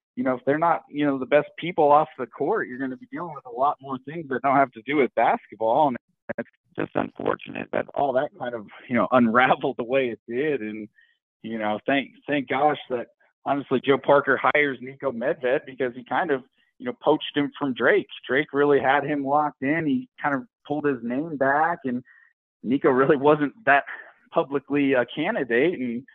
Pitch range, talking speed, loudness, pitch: 125-145 Hz, 210 wpm, -24 LUFS, 140 Hz